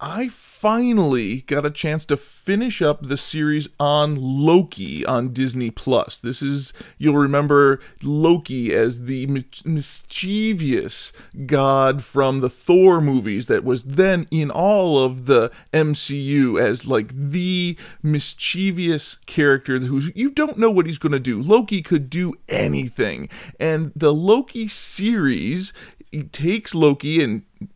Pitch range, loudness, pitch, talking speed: 135-180 Hz, -20 LUFS, 150 Hz, 135 wpm